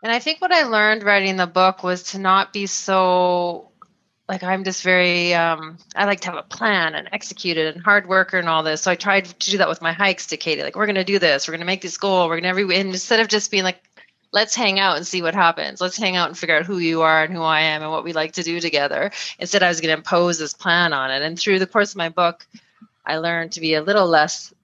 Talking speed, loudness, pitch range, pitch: 285 wpm, -19 LUFS, 165-200 Hz, 180 Hz